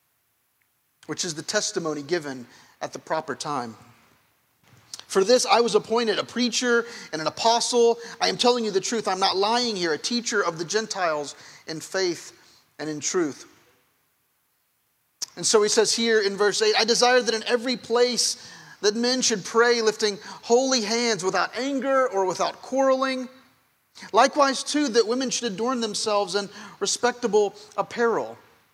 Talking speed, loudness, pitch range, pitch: 155 wpm, -23 LUFS, 195-245 Hz, 225 Hz